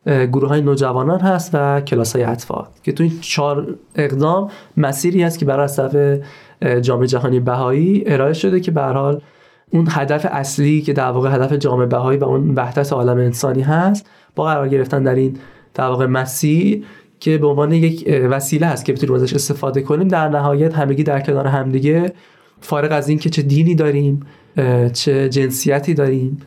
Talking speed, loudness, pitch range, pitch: 170 wpm, -16 LUFS, 135-155 Hz, 140 Hz